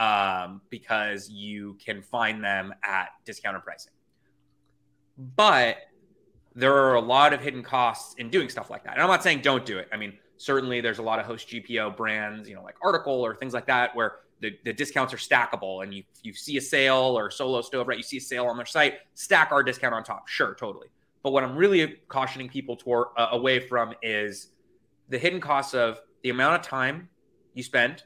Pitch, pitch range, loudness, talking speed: 120 Hz, 105-135 Hz, -25 LUFS, 210 wpm